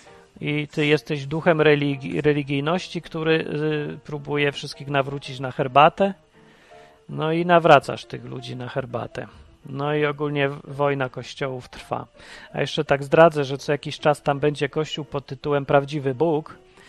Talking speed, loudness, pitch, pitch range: 145 wpm, -22 LUFS, 145 Hz, 140-155 Hz